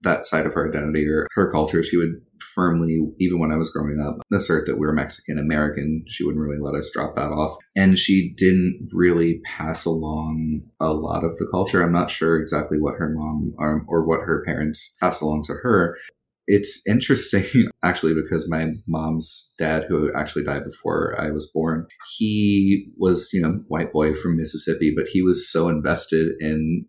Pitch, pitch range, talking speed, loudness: 80 Hz, 75-85 Hz, 190 wpm, -22 LUFS